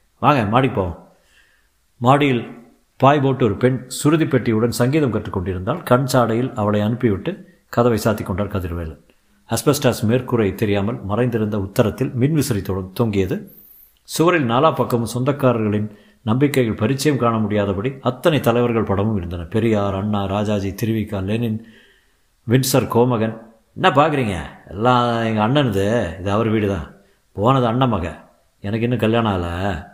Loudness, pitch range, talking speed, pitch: -19 LUFS, 105-125 Hz, 120 wpm, 115 Hz